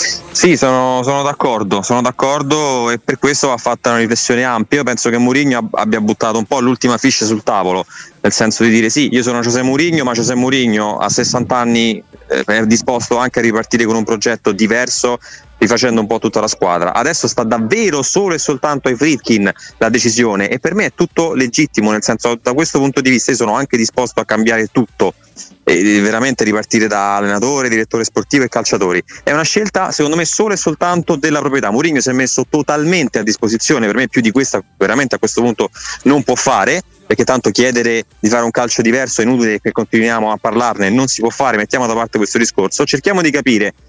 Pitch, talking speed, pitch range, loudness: 120 Hz, 205 wpm, 115-135 Hz, -13 LUFS